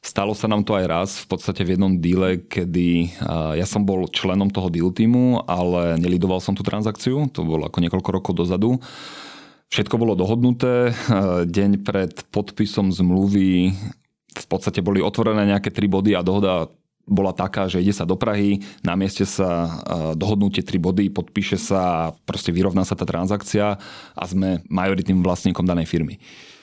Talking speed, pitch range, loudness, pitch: 165 wpm, 90-100 Hz, -21 LUFS, 95 Hz